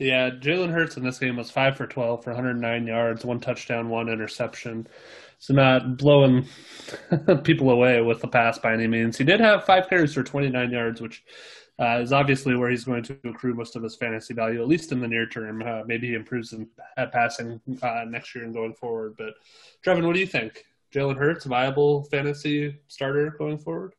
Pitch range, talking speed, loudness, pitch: 115-145 Hz, 205 wpm, -23 LUFS, 125 Hz